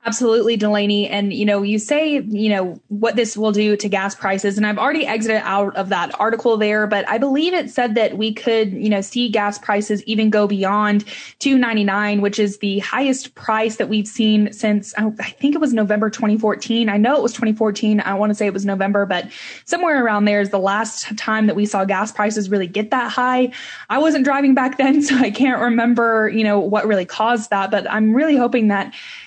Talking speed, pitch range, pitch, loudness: 215 wpm, 205-240 Hz, 215 Hz, -18 LUFS